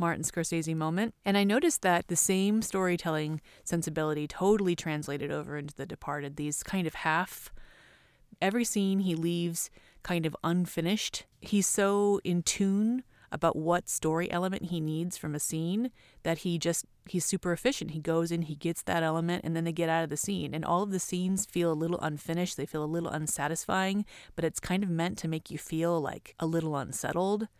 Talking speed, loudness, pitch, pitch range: 195 wpm, -31 LUFS, 170 Hz, 160-190 Hz